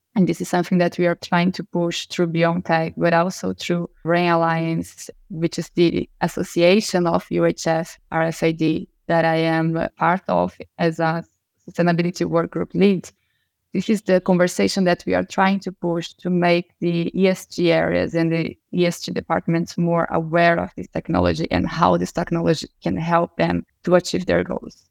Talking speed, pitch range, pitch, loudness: 170 wpm, 165-180 Hz, 170 Hz, -20 LUFS